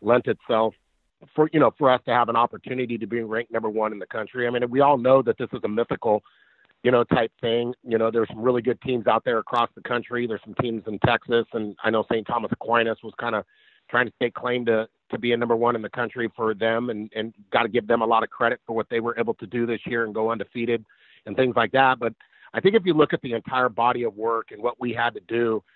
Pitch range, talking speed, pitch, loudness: 115-125 Hz, 275 wpm, 115 Hz, -24 LUFS